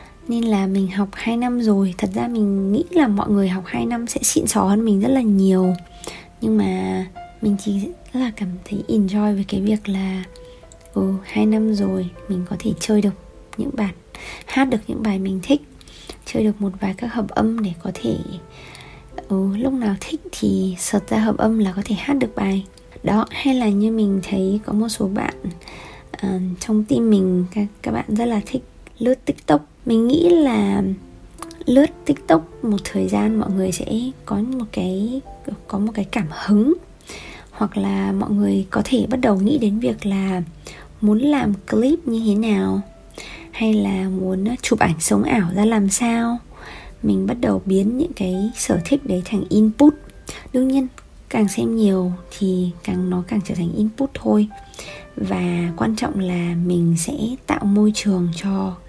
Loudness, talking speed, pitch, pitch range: -20 LUFS, 190 wpm, 205 Hz, 190-230 Hz